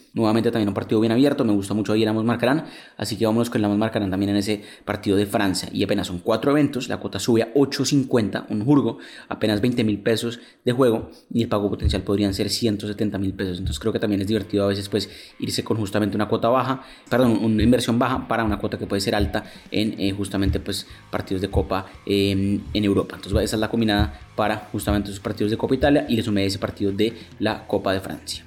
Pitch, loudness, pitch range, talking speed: 105 Hz, -22 LUFS, 100-115 Hz, 230 wpm